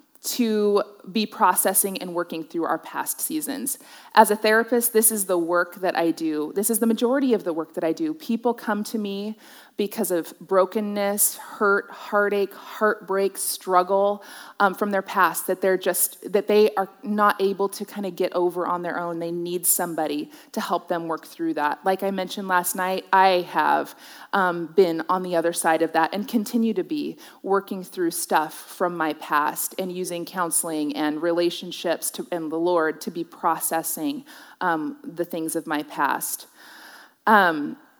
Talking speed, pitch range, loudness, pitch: 180 wpm, 175-215 Hz, -23 LUFS, 190 Hz